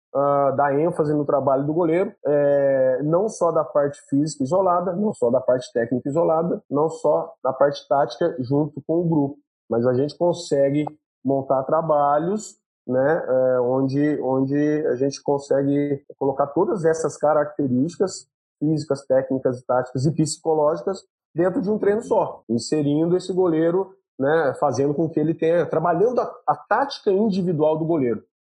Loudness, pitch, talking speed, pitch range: -21 LUFS, 150 Hz, 150 wpm, 140-165 Hz